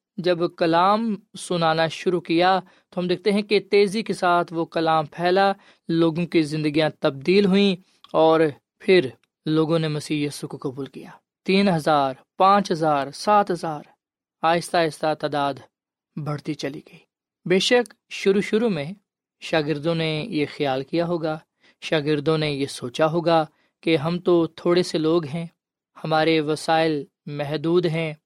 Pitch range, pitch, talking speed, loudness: 155-185 Hz, 165 Hz, 145 wpm, -22 LUFS